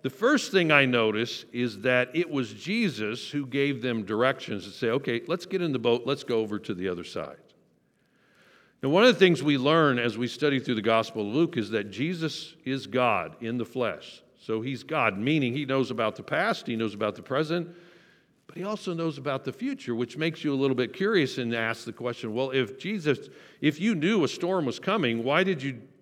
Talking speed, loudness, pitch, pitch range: 225 wpm, -27 LUFS, 135 Hz, 120-165 Hz